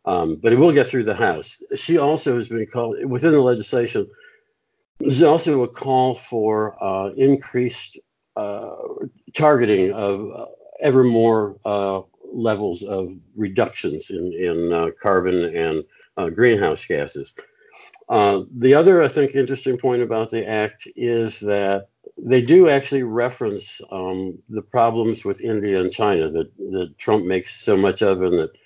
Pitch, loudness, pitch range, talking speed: 115 Hz, -19 LUFS, 100-135 Hz, 155 wpm